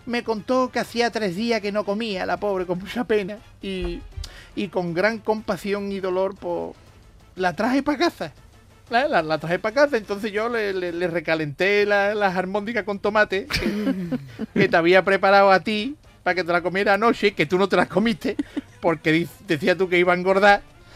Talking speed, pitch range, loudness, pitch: 205 wpm, 180-215 Hz, -22 LUFS, 200 Hz